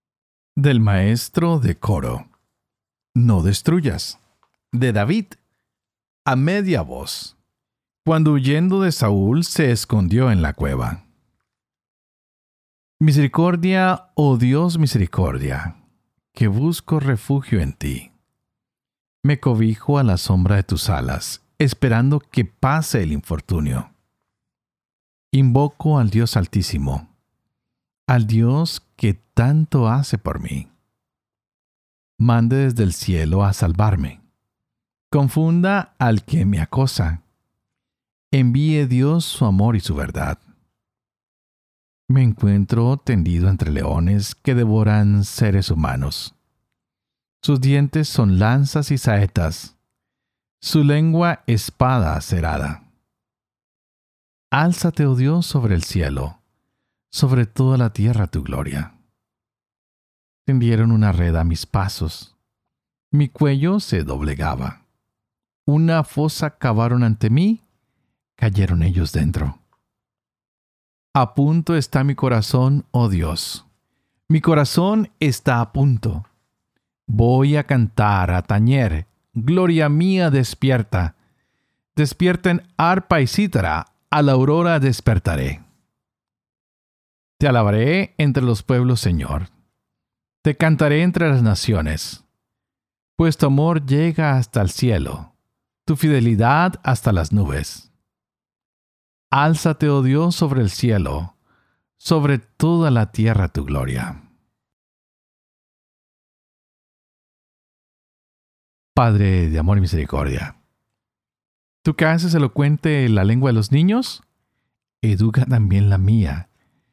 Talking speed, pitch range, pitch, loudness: 105 wpm, 95-145 Hz, 120 Hz, -18 LUFS